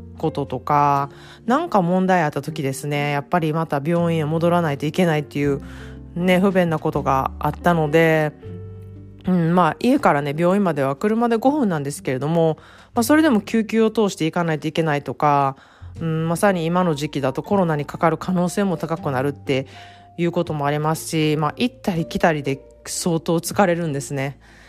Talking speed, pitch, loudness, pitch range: 370 characters per minute, 160 Hz, -20 LUFS, 140-180 Hz